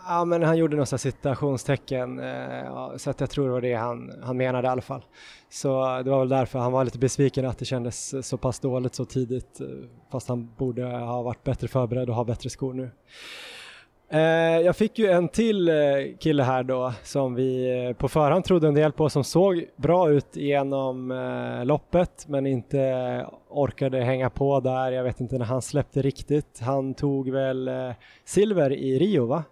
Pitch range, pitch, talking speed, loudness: 125-145 Hz, 130 Hz, 180 wpm, -25 LUFS